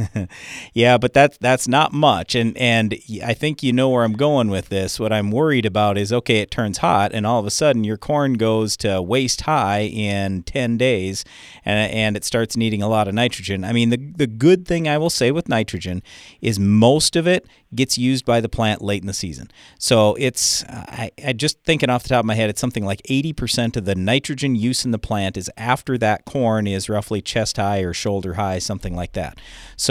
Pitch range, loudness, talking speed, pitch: 100-130 Hz, -19 LUFS, 225 wpm, 115 Hz